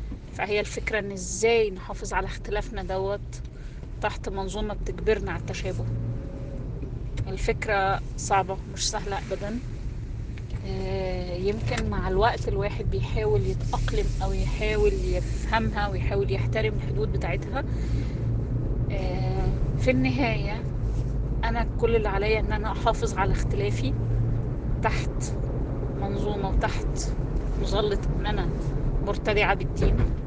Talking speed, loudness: 100 wpm, -28 LUFS